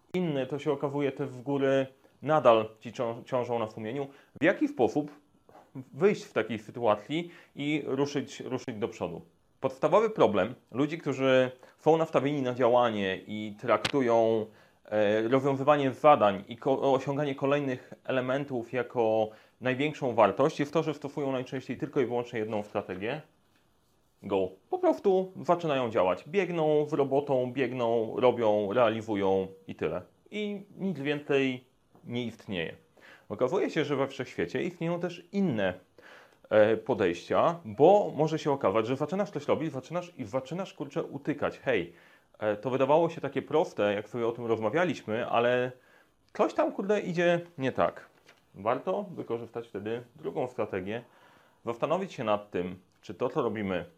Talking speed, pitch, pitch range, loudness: 140 wpm, 135 Hz, 115-155 Hz, -29 LUFS